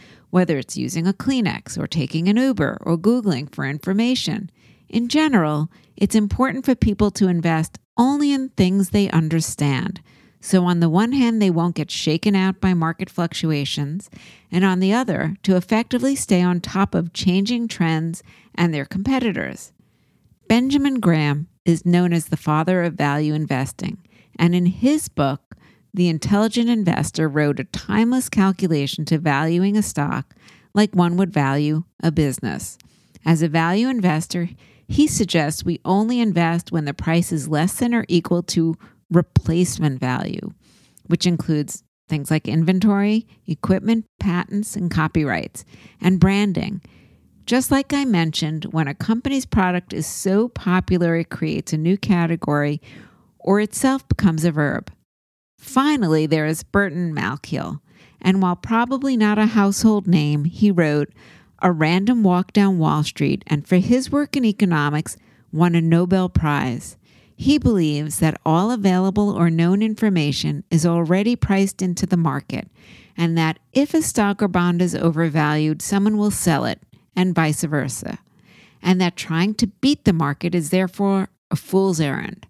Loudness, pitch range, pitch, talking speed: -20 LUFS, 160-205 Hz, 180 Hz, 150 wpm